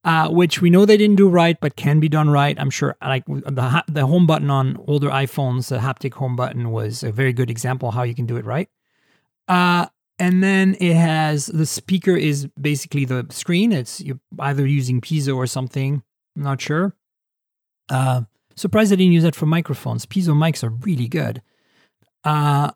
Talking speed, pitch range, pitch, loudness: 200 wpm, 130-170 Hz, 145 Hz, -19 LUFS